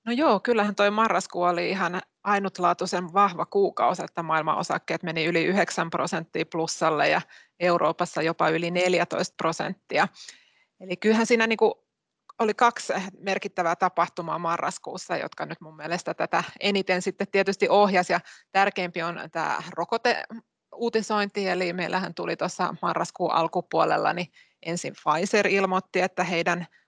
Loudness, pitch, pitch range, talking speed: -25 LUFS, 180 Hz, 170-205 Hz, 130 wpm